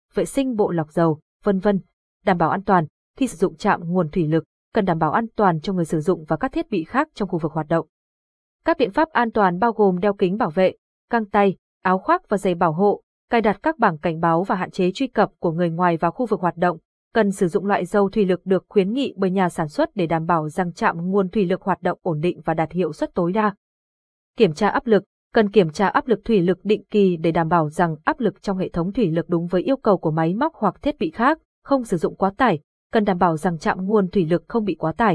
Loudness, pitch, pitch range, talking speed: -21 LUFS, 190 Hz, 175-215 Hz, 270 wpm